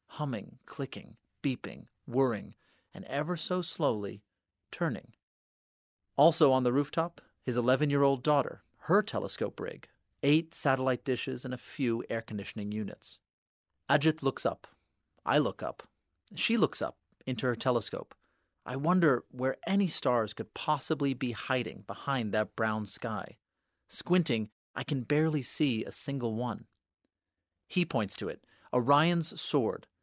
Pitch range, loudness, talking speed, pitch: 115-150 Hz, -31 LUFS, 140 wpm, 130 Hz